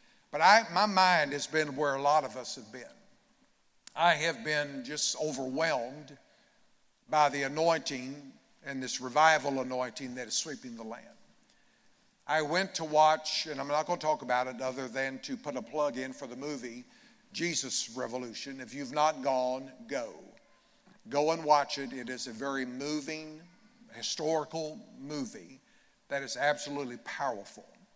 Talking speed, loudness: 160 wpm, -31 LUFS